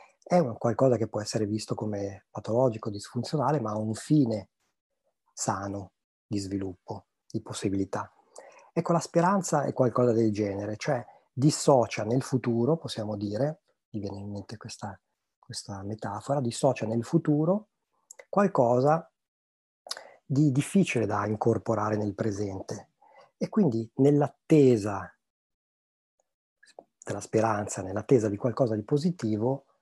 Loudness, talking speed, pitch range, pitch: -28 LUFS, 120 wpm, 105-140 Hz, 115 Hz